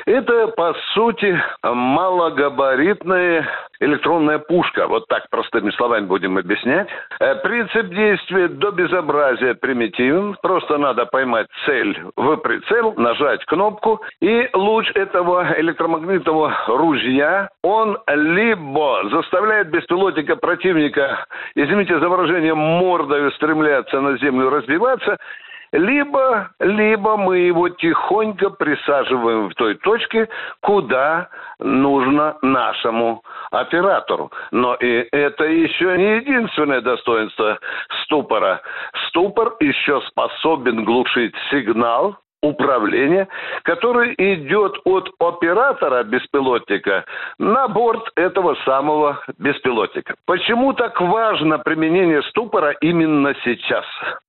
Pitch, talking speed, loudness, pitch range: 175 Hz, 95 wpm, -17 LUFS, 145-215 Hz